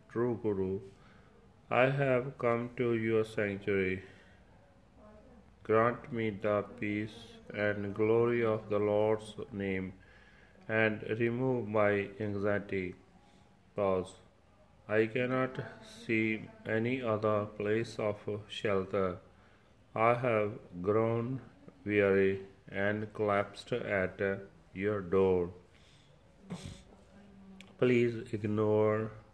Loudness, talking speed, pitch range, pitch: -33 LUFS, 85 wpm, 100-115 Hz, 105 Hz